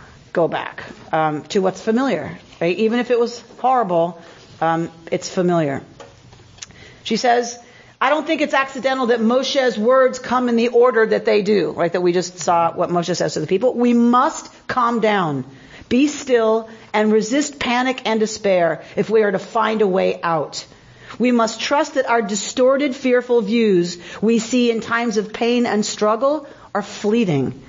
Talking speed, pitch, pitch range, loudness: 175 wpm, 225 Hz, 180-245 Hz, -18 LUFS